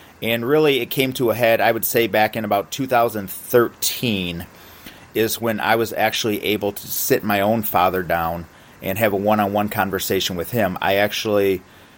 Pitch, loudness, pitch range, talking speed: 105 Hz, -20 LUFS, 95-115 Hz, 185 wpm